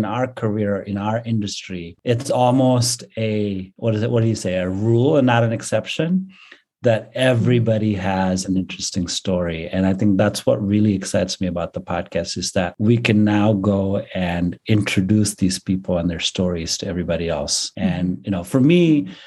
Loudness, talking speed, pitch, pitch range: -20 LUFS, 185 wpm, 105 Hz, 95-115 Hz